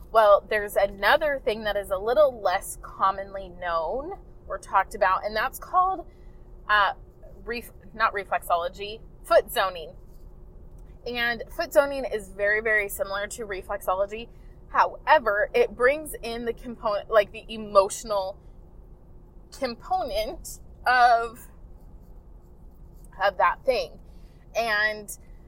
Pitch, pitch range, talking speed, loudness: 210 Hz, 190-240 Hz, 110 wpm, -25 LUFS